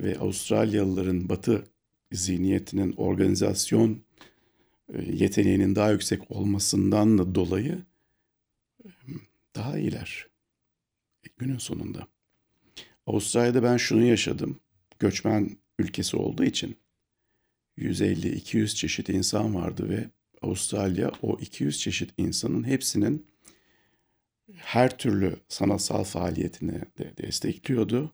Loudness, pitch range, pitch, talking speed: -26 LUFS, 95-115 Hz, 105 Hz, 85 wpm